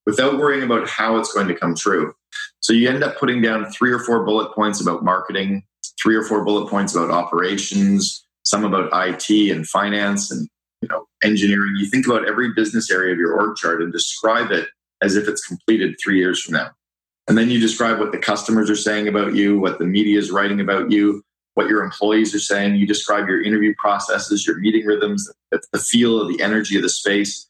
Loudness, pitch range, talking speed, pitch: -18 LUFS, 100-110 Hz, 215 wpm, 105 Hz